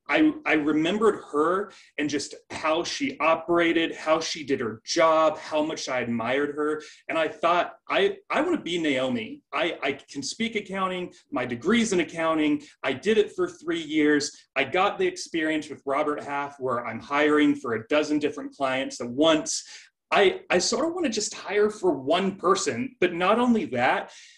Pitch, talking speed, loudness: 170 Hz, 185 wpm, -25 LUFS